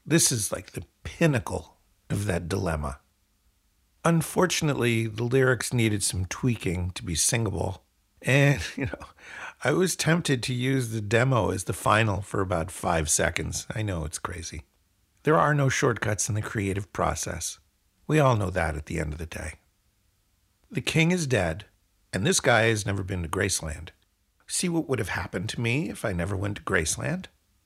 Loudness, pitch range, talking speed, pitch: -26 LUFS, 90-125 Hz, 175 wpm, 100 Hz